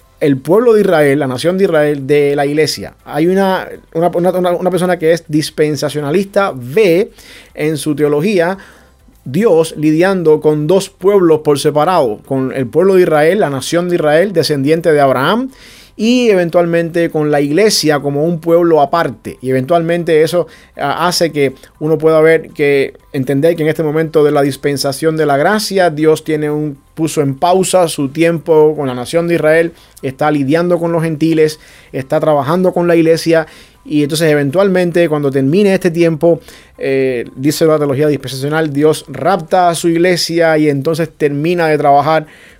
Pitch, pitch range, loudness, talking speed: 160 Hz, 145-170 Hz, -12 LUFS, 165 wpm